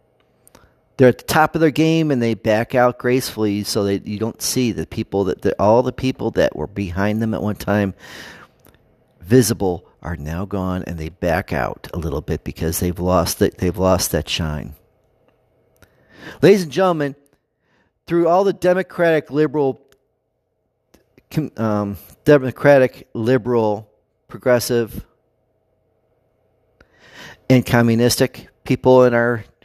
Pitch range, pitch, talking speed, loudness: 100-130 Hz, 115 Hz, 135 wpm, -18 LUFS